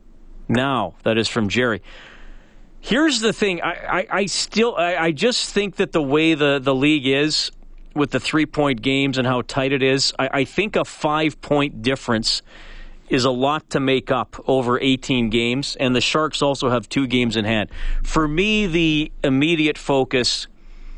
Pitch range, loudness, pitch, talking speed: 130-160 Hz, -19 LUFS, 140 Hz, 175 wpm